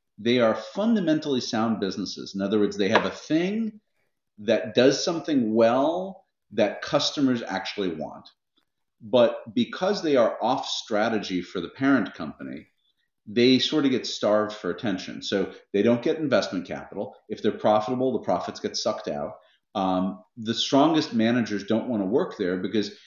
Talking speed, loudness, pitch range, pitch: 160 wpm, -25 LUFS, 105-155 Hz, 120 Hz